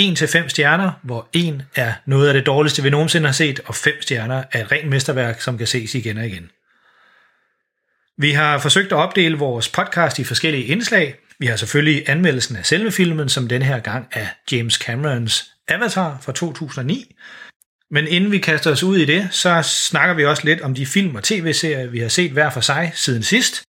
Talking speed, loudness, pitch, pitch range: 205 wpm, -17 LUFS, 150 Hz, 130-165 Hz